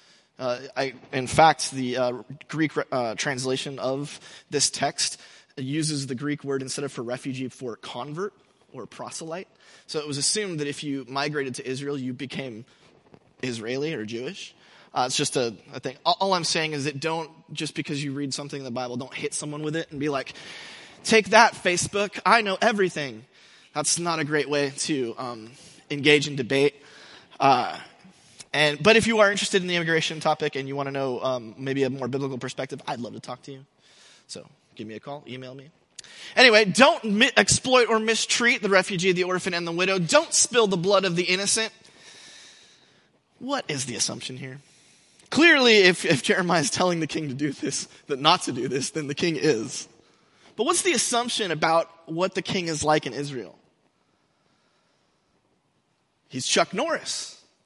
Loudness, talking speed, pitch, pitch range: -23 LUFS, 185 wpm, 150 Hz, 135-185 Hz